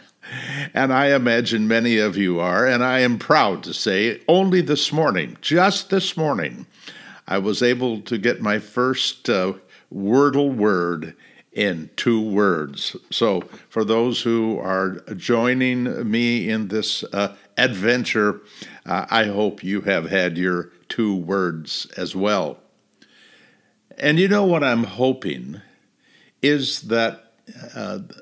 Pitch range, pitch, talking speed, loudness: 100-130 Hz, 115 Hz, 135 wpm, -20 LUFS